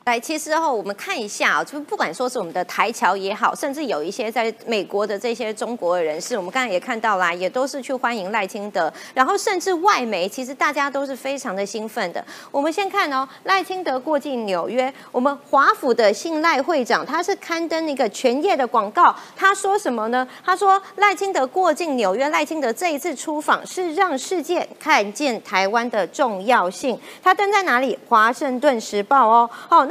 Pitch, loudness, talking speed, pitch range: 265 Hz, -20 LUFS, 305 characters per minute, 225-330 Hz